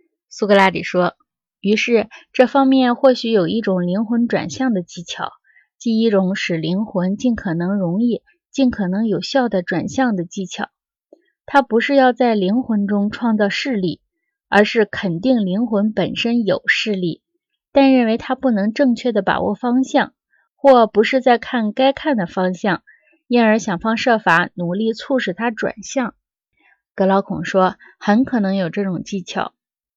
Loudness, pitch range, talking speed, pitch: -18 LUFS, 195-255 Hz, 230 characters per minute, 220 Hz